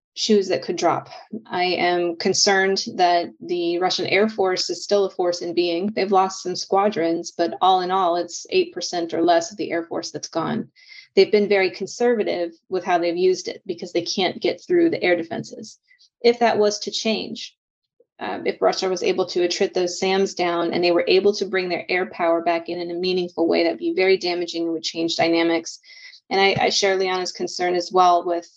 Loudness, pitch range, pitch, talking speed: -21 LUFS, 175-200 Hz, 185 Hz, 210 wpm